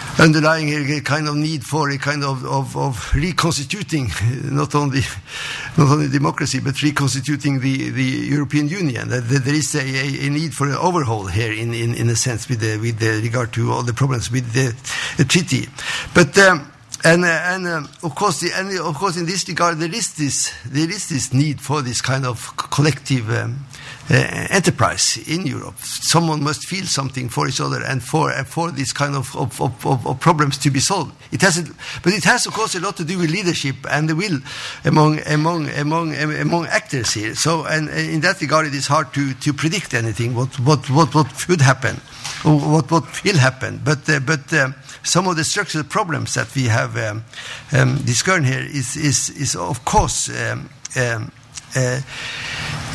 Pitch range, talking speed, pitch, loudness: 130-160 Hz, 195 wpm, 145 Hz, -18 LUFS